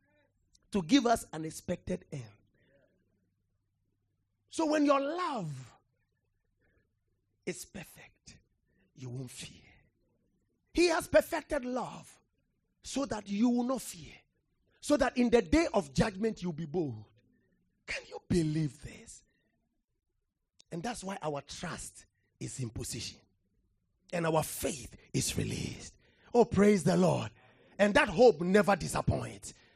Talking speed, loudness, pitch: 125 wpm, -31 LUFS, 160 Hz